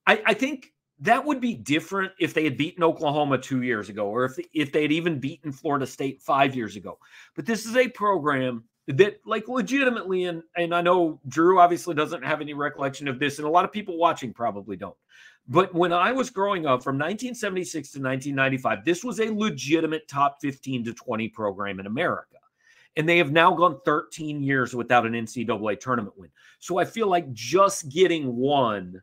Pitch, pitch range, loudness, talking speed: 155 Hz, 135-185 Hz, -24 LUFS, 200 wpm